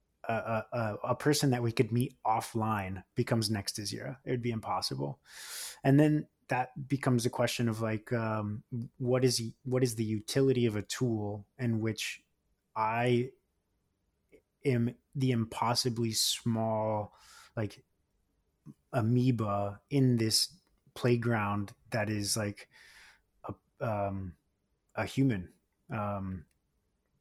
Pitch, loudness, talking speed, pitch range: 115 Hz, -32 LUFS, 120 wpm, 100-125 Hz